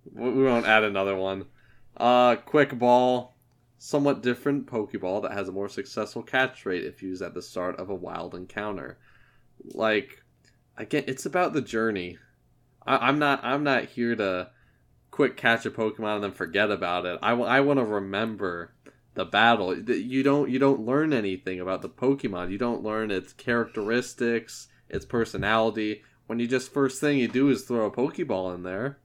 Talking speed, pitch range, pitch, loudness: 180 wpm, 100-130 Hz, 120 Hz, -26 LUFS